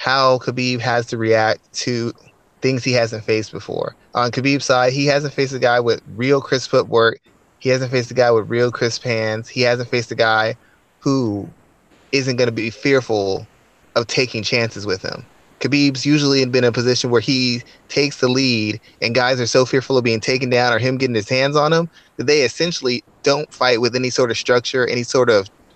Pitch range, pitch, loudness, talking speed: 115-135 Hz, 125 Hz, -18 LUFS, 205 wpm